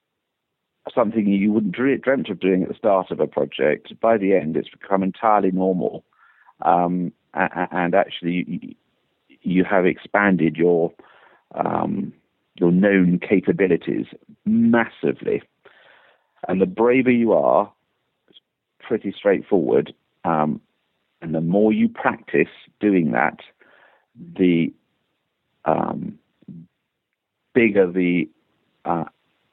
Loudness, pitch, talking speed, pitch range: -20 LUFS, 95 Hz, 110 wpm, 90-105 Hz